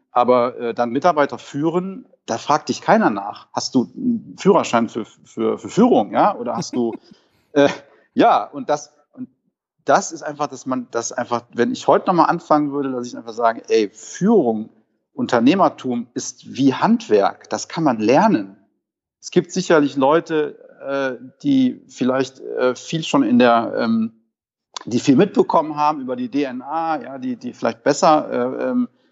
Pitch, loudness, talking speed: 145 Hz, -19 LUFS, 165 wpm